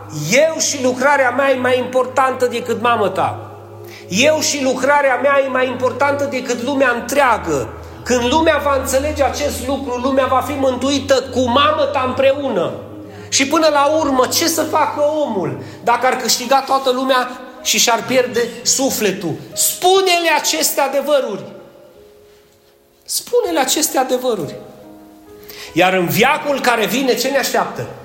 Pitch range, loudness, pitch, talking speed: 210-280 Hz, -15 LUFS, 255 Hz, 135 wpm